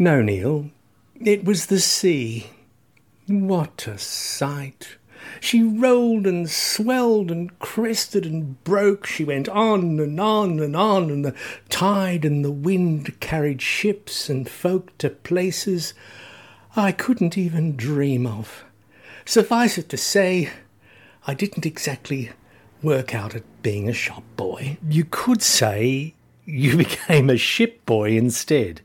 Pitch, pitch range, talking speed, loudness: 155 Hz, 130-195 Hz, 135 wpm, -21 LUFS